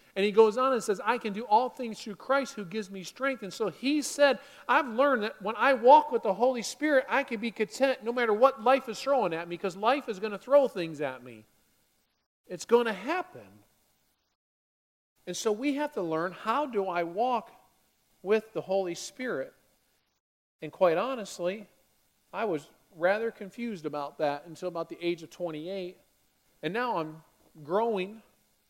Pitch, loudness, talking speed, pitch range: 210 Hz, -29 LUFS, 185 wpm, 170-250 Hz